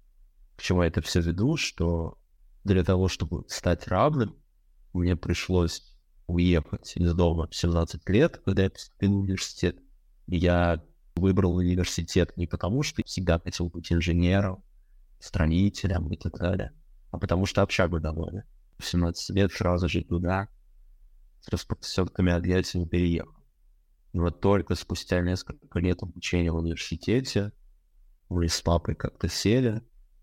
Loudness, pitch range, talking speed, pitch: -27 LUFS, 85-95 Hz, 135 wpm, 90 Hz